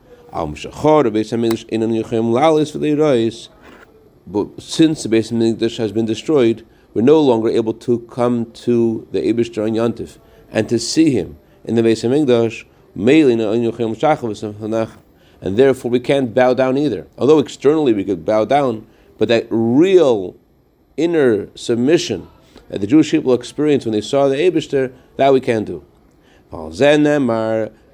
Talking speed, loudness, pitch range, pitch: 120 wpm, -16 LUFS, 110-140 Hz, 115 Hz